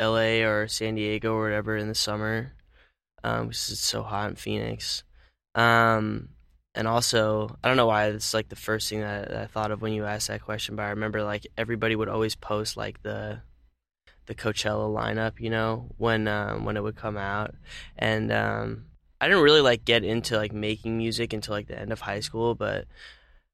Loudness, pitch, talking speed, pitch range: -26 LUFS, 110 Hz, 195 wpm, 105-115 Hz